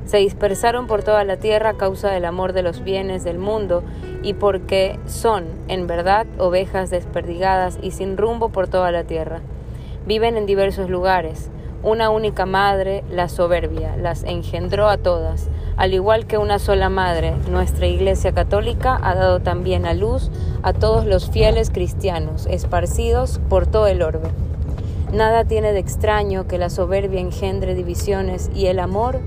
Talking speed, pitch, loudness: 160 wpm, 175 Hz, -19 LUFS